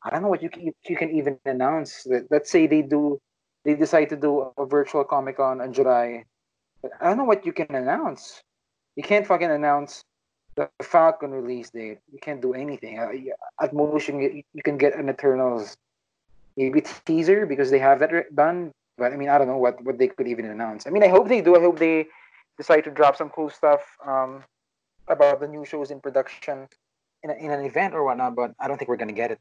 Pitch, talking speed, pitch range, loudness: 145 Hz, 215 wpm, 130-155 Hz, -22 LUFS